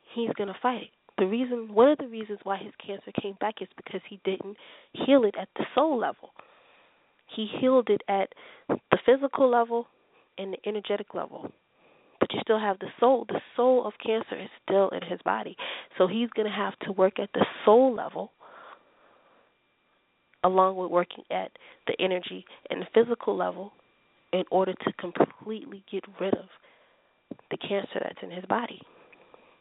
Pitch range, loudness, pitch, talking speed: 190-240 Hz, -27 LUFS, 210 Hz, 170 wpm